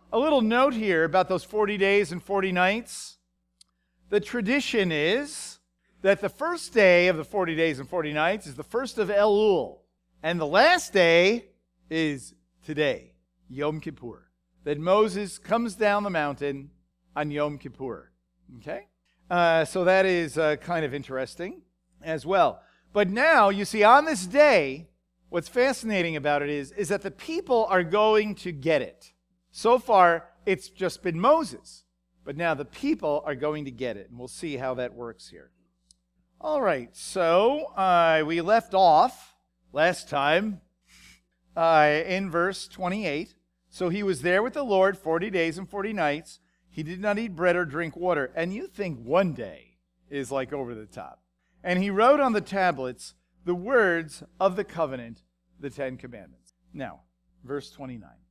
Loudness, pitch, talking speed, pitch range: -24 LUFS, 170 Hz, 165 wpm, 130-200 Hz